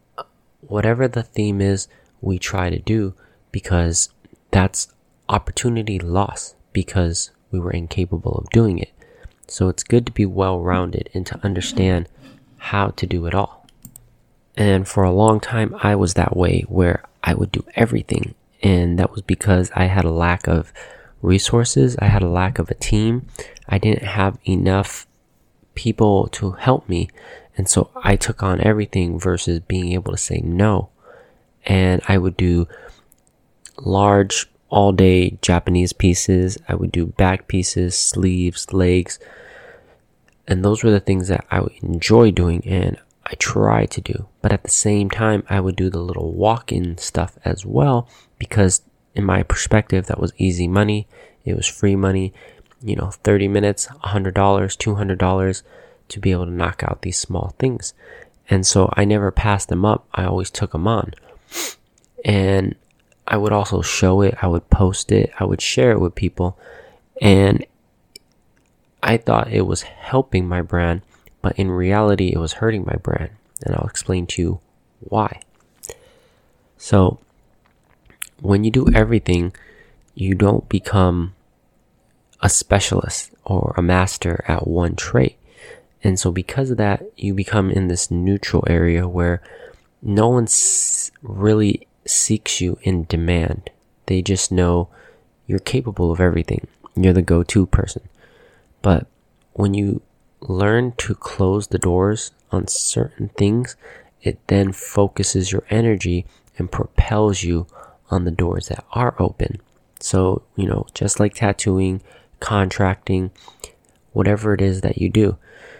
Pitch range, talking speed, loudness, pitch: 90-105 Hz, 150 wpm, -19 LUFS, 95 Hz